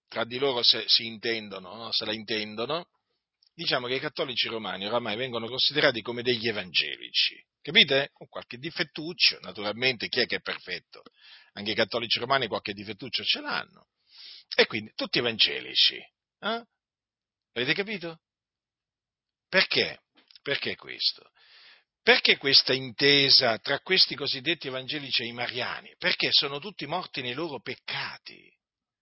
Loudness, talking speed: -25 LUFS, 135 wpm